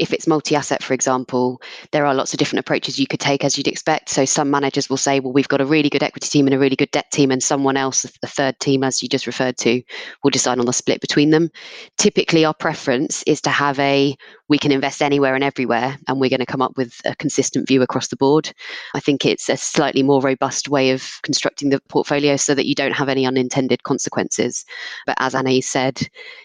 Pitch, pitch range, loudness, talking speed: 140 Hz, 130-145 Hz, -18 LUFS, 240 wpm